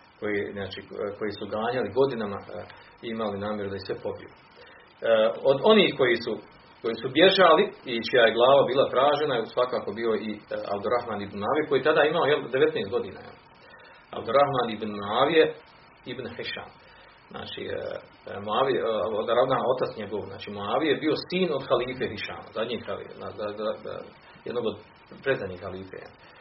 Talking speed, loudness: 130 wpm, -25 LUFS